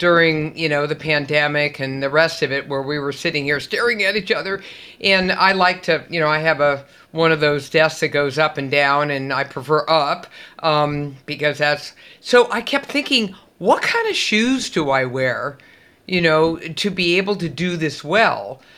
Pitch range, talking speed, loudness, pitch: 145-185 Hz, 205 wpm, -18 LUFS, 155 Hz